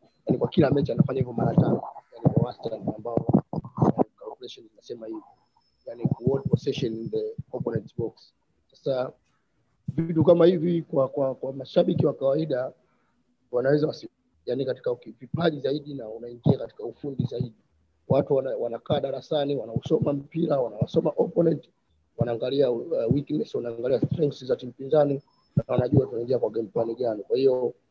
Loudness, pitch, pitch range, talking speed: -26 LUFS, 150 Hz, 130-175 Hz, 100 wpm